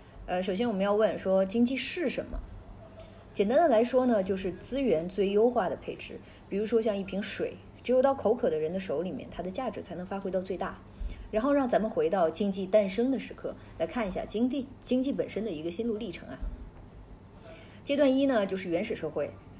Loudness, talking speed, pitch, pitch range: -29 LUFS, 305 characters per minute, 210 Hz, 190-245 Hz